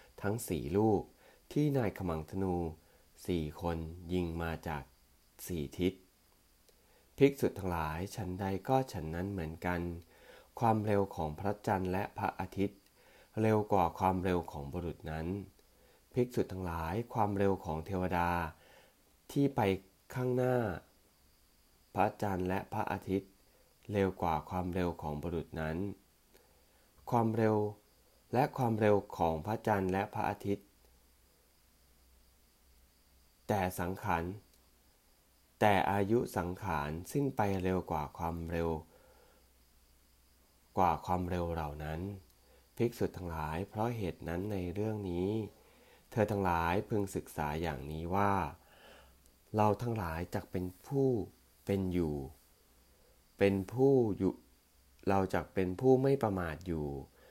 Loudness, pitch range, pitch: -35 LUFS, 80-100 Hz, 90 Hz